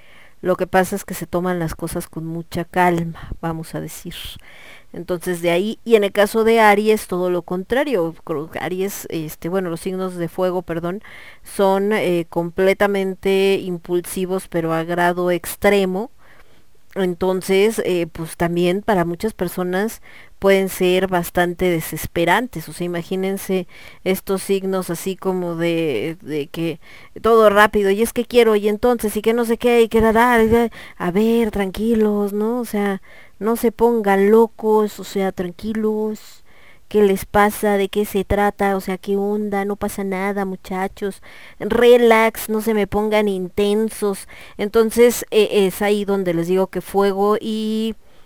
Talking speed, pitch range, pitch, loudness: 155 wpm, 180-215 Hz, 195 Hz, -19 LUFS